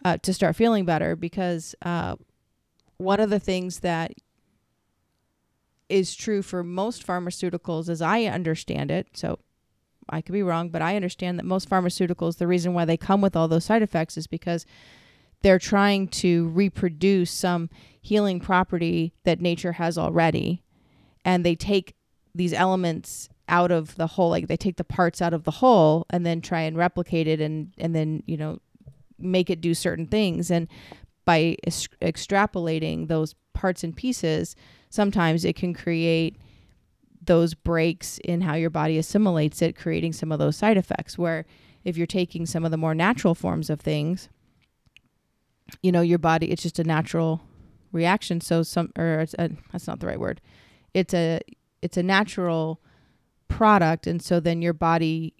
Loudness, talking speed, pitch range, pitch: -24 LUFS, 170 wpm, 165-185 Hz, 170 Hz